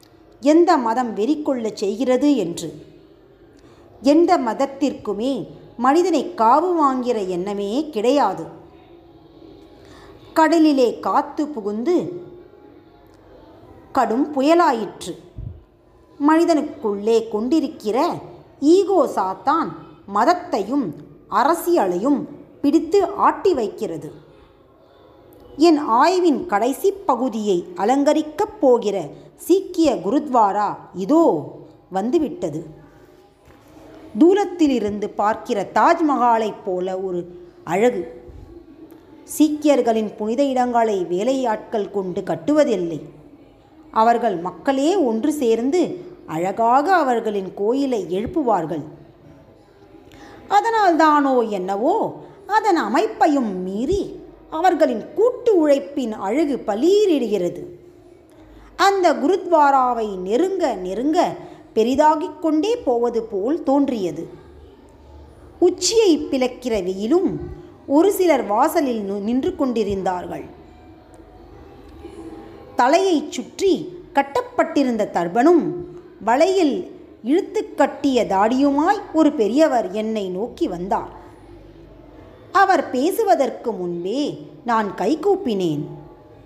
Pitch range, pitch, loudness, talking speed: 220-340 Hz, 280 Hz, -19 LUFS, 70 wpm